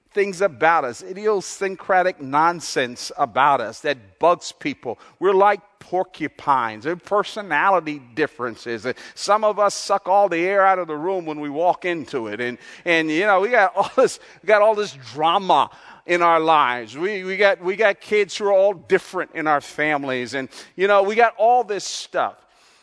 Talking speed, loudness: 185 wpm, -20 LUFS